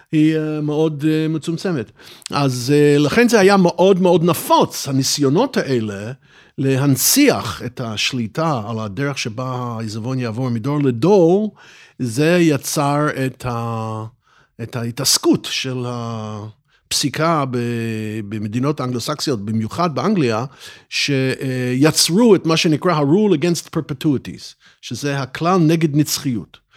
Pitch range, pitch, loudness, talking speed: 120-160 Hz, 140 Hz, -17 LUFS, 100 wpm